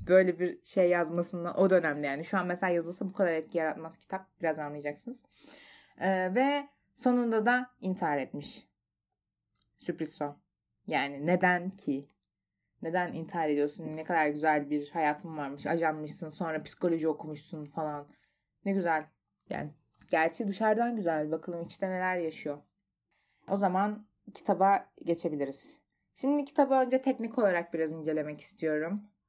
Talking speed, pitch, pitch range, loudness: 135 wpm, 170 Hz, 155-195 Hz, -31 LUFS